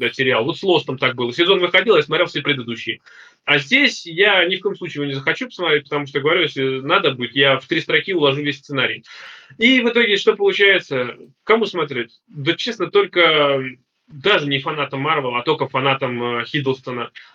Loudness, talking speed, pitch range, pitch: -17 LUFS, 195 wpm, 135-185 Hz, 145 Hz